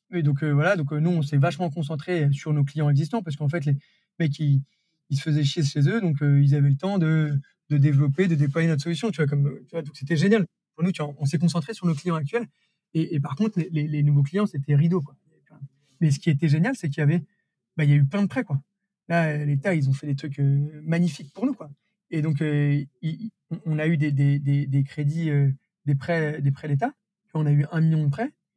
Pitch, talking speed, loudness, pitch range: 155 Hz, 275 wpm, -24 LUFS, 145-170 Hz